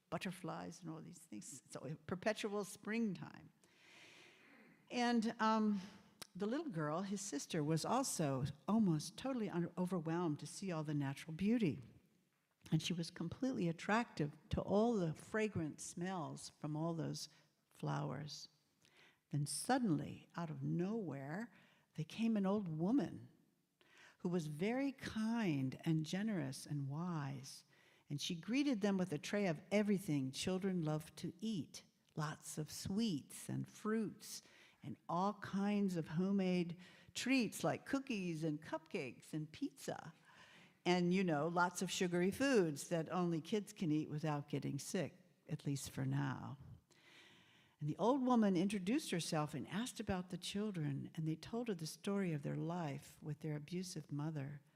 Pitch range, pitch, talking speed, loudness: 155-205 Hz, 175 Hz, 145 wpm, -41 LUFS